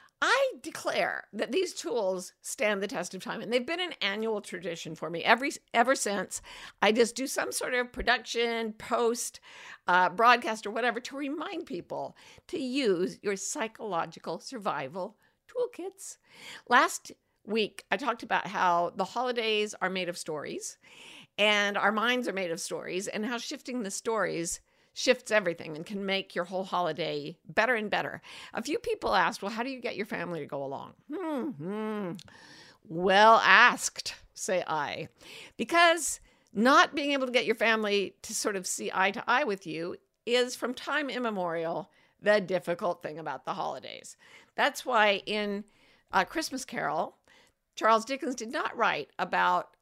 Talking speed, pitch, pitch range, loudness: 165 wpm, 220 Hz, 190-255 Hz, -29 LUFS